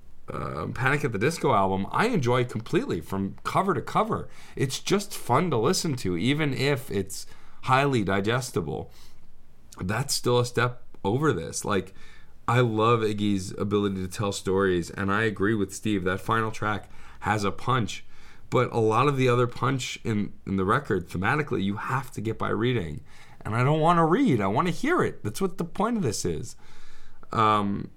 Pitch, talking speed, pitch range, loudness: 110 Hz, 195 wpm, 100-130 Hz, -26 LUFS